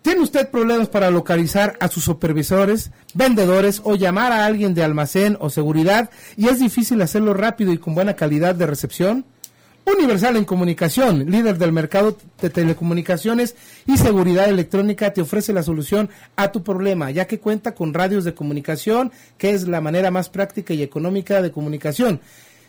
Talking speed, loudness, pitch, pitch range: 165 wpm, -18 LUFS, 195 Hz, 170-215 Hz